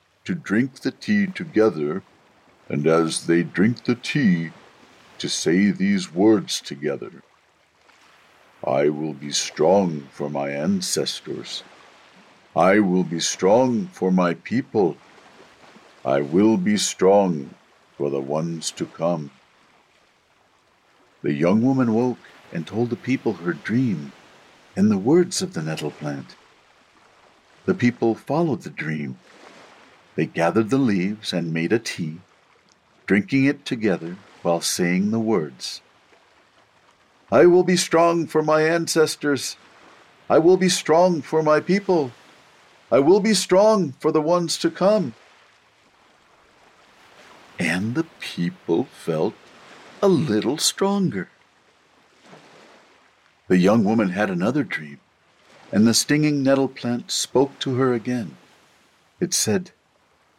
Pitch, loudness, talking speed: 120 Hz, -21 LUFS, 120 wpm